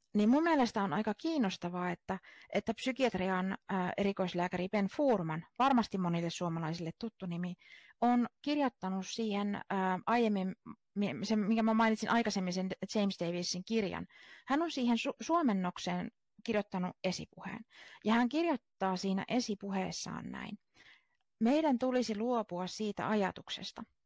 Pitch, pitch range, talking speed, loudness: 210 Hz, 185-235 Hz, 125 wpm, -34 LUFS